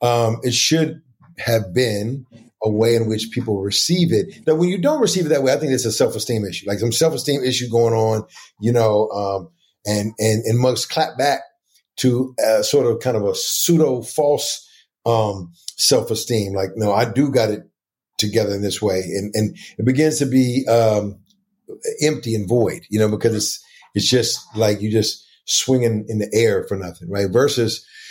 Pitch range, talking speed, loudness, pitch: 110-150 Hz, 195 wpm, -19 LUFS, 115 Hz